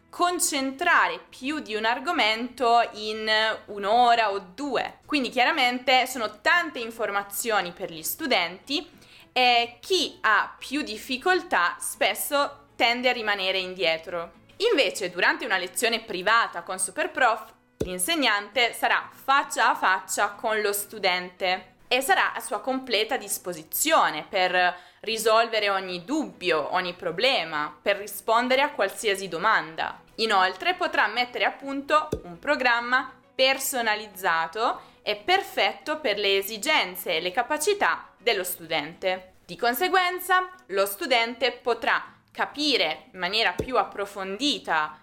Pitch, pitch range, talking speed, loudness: 230 Hz, 195-275 Hz, 115 wpm, -24 LUFS